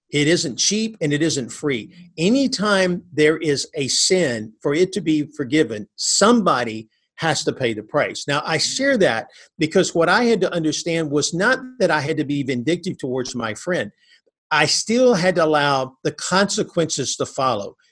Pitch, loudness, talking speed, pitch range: 160 Hz, -19 LUFS, 175 wpm, 145-185 Hz